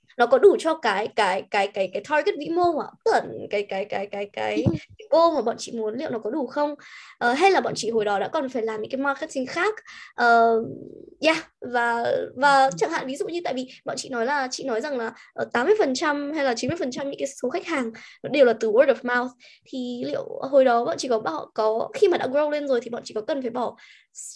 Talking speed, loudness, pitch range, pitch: 260 wpm, -23 LUFS, 230-315 Hz, 265 Hz